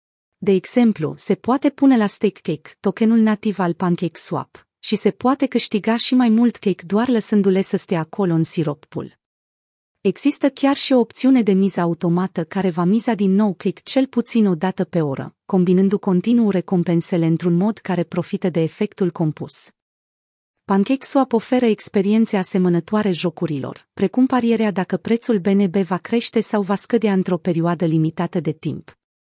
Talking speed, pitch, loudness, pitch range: 165 wpm, 195 Hz, -19 LUFS, 175-225 Hz